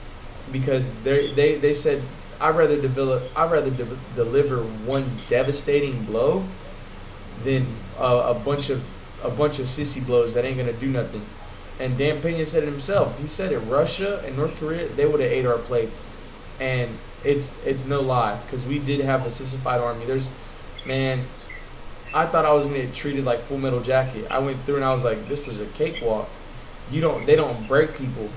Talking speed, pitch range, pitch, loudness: 190 wpm, 120-145 Hz, 130 Hz, -23 LUFS